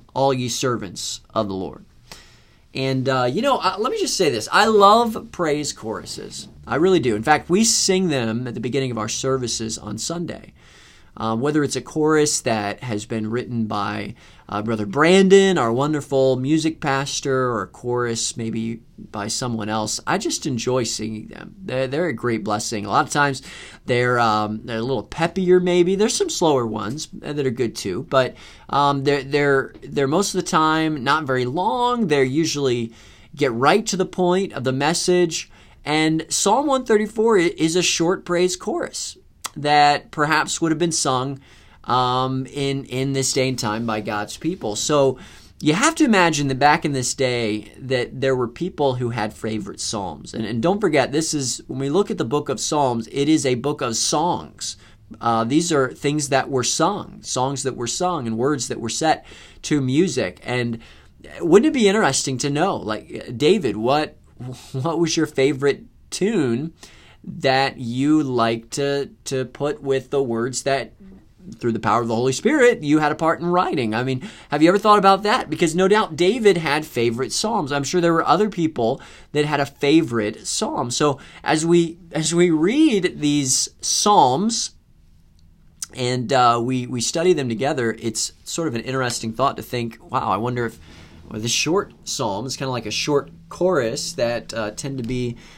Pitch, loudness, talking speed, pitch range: 135 Hz, -20 LUFS, 185 wpm, 115-165 Hz